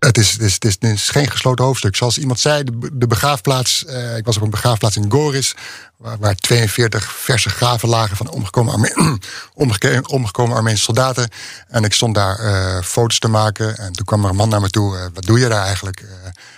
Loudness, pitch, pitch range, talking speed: -16 LUFS, 115 Hz, 105-125 Hz, 205 wpm